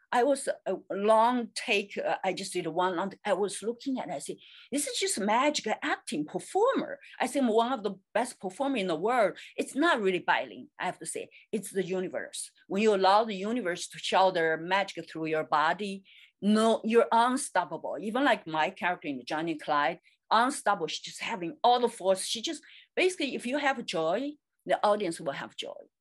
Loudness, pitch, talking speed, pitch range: -29 LUFS, 205 Hz, 195 wpm, 180-250 Hz